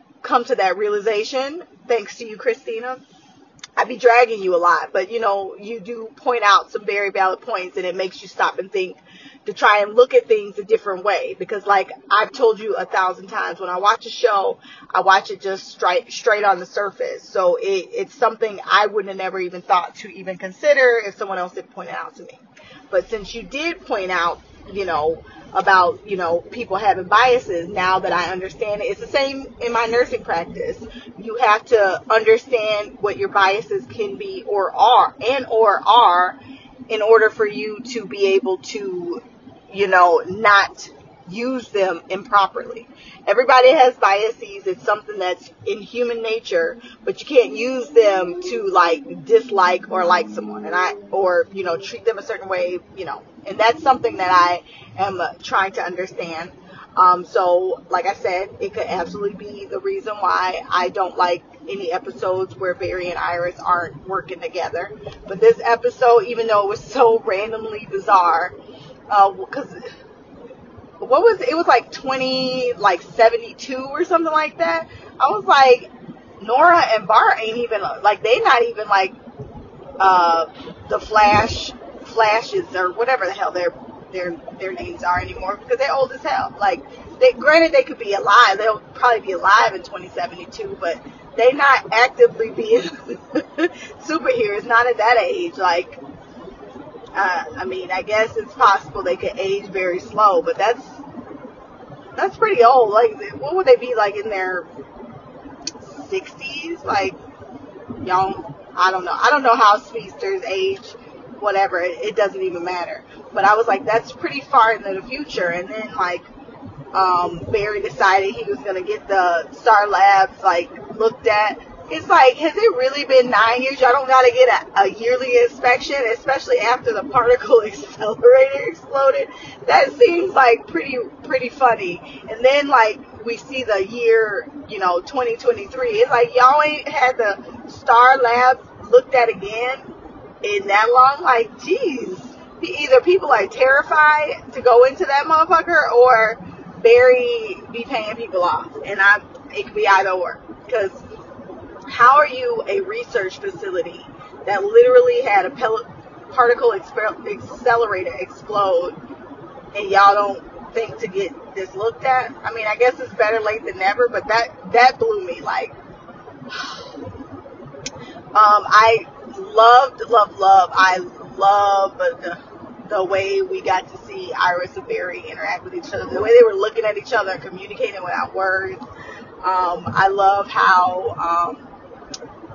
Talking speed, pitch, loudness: 170 wpm, 235 Hz, -17 LUFS